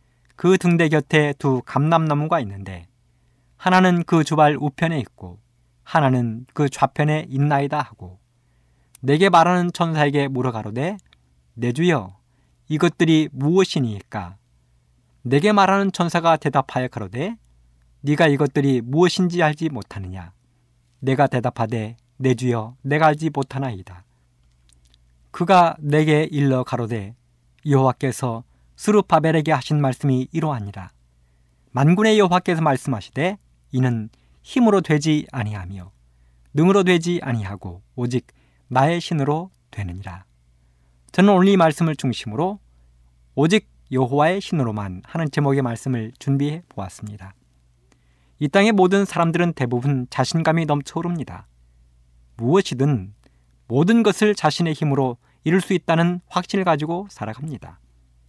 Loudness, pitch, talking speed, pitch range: -20 LUFS, 135 Hz, 285 characters per minute, 105-165 Hz